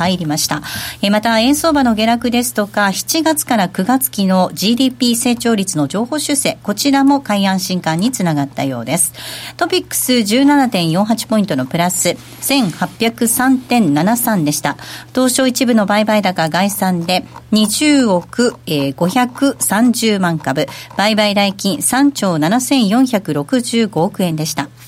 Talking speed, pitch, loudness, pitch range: 220 characters per minute, 215 Hz, -14 LUFS, 180-245 Hz